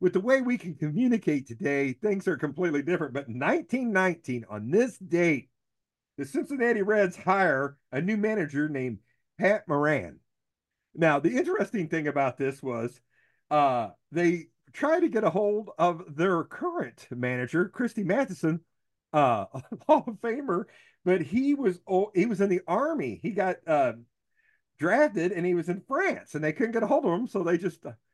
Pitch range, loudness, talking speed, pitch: 145-225 Hz, -27 LUFS, 170 wpm, 180 Hz